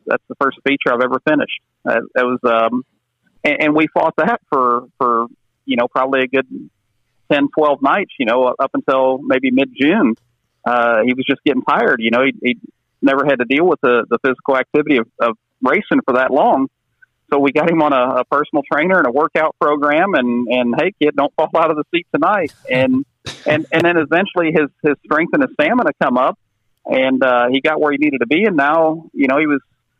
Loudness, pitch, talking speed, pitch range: -15 LUFS, 135 Hz, 220 wpm, 125-155 Hz